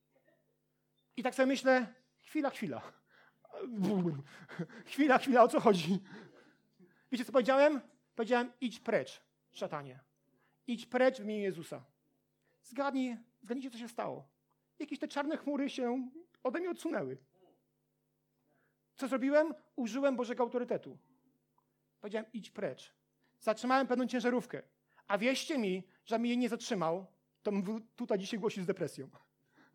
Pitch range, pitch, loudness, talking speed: 200-265 Hz, 240 Hz, -34 LUFS, 125 wpm